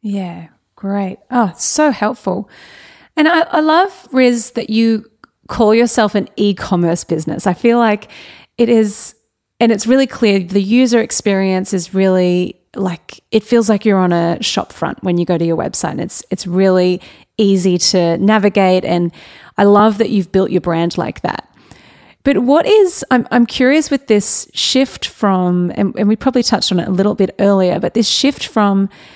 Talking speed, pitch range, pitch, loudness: 180 wpm, 185-235 Hz, 205 Hz, -14 LUFS